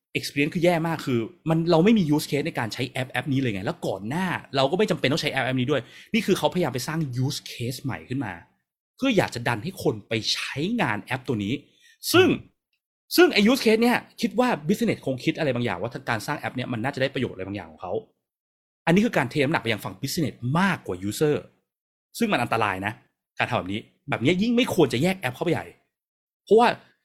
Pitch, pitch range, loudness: 145 Hz, 125-175 Hz, -24 LUFS